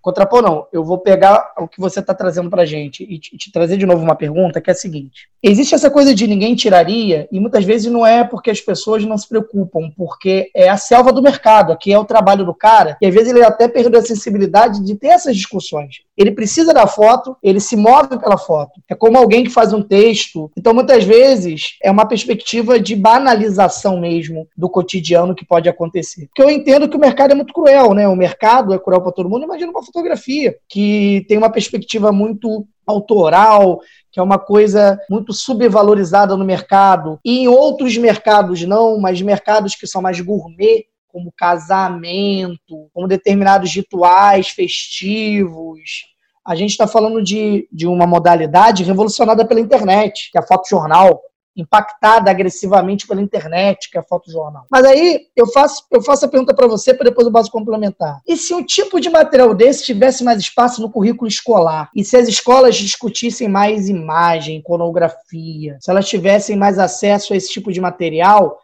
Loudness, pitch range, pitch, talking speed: -12 LUFS, 185-230 Hz, 205 Hz, 190 wpm